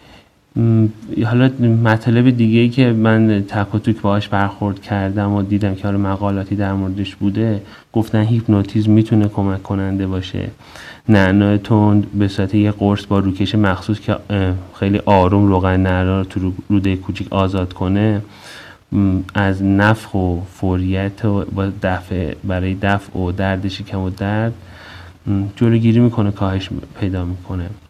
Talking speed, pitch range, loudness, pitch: 130 wpm, 95-105 Hz, -17 LUFS, 100 Hz